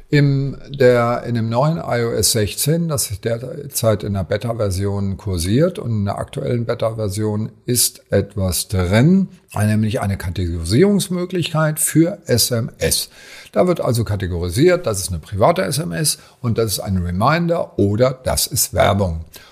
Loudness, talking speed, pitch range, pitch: -18 LUFS, 140 wpm, 100-145 Hz, 115 Hz